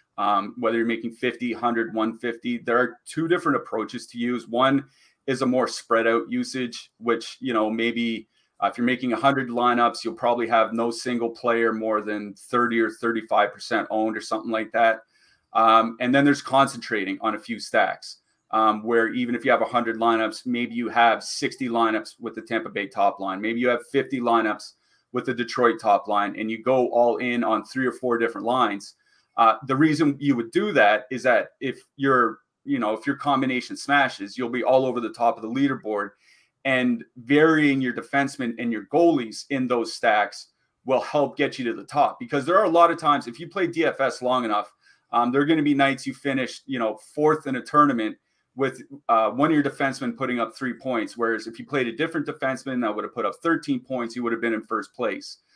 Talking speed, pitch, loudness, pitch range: 215 wpm, 120 Hz, -23 LUFS, 115-135 Hz